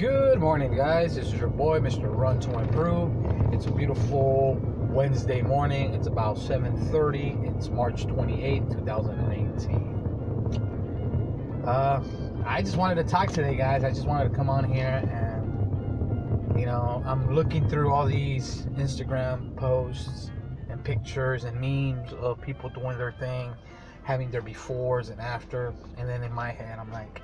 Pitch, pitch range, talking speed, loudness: 120 Hz, 115-130 Hz, 160 wpm, -27 LUFS